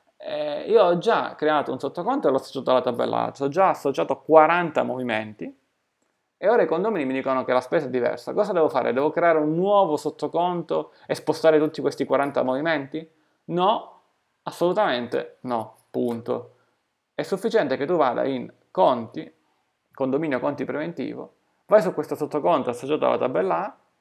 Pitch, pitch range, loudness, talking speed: 155 Hz, 135-175 Hz, -23 LUFS, 160 wpm